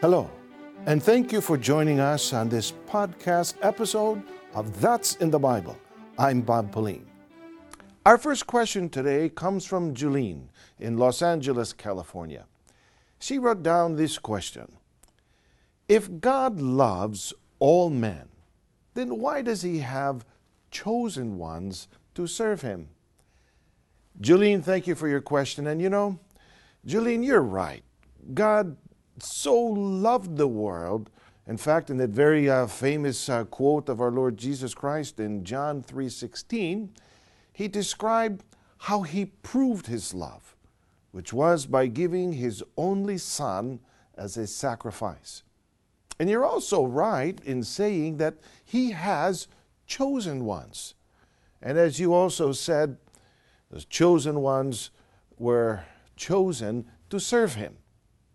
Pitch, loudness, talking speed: 145 Hz, -26 LUFS, 130 wpm